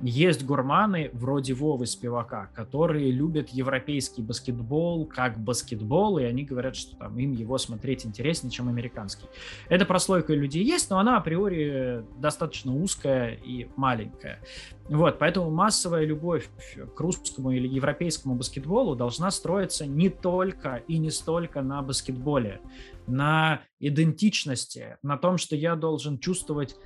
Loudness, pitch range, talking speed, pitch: -27 LUFS, 125-165 Hz, 130 wpm, 140 Hz